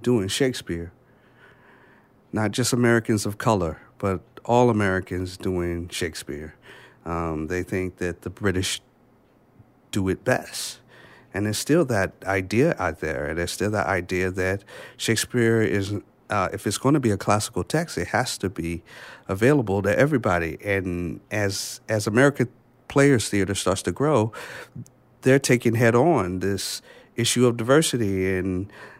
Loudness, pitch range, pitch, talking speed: -23 LUFS, 95-120 Hz, 105 Hz, 150 wpm